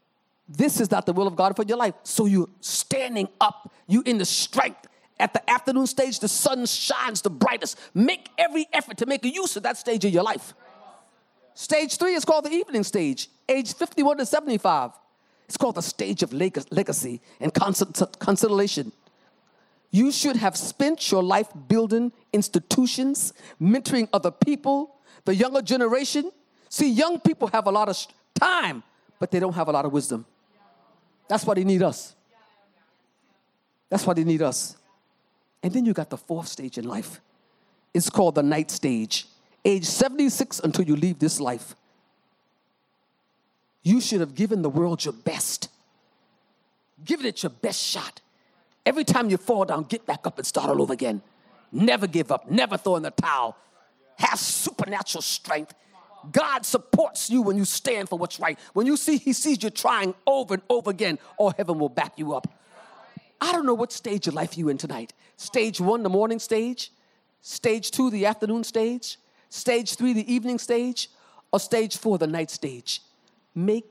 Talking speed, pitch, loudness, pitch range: 175 wpm, 220 Hz, -24 LUFS, 190-255 Hz